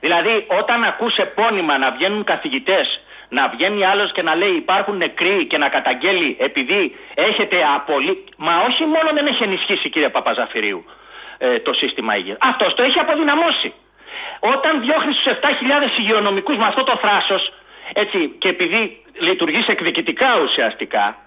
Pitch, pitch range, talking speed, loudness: 250 Hz, 195-315 Hz, 145 wpm, -17 LUFS